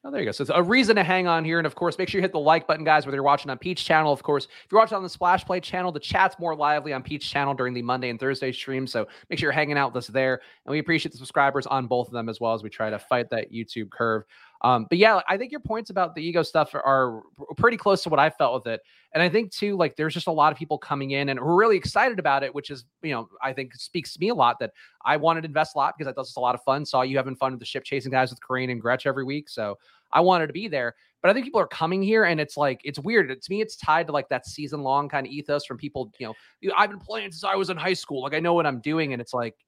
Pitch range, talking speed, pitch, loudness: 130-170 Hz, 325 wpm, 145 Hz, -24 LUFS